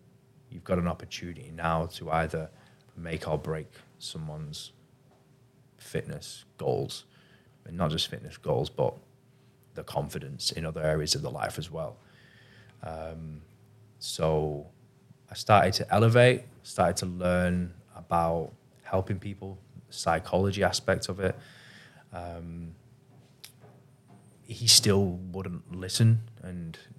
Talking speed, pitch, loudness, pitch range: 115 wpm, 95 Hz, -28 LUFS, 85-120 Hz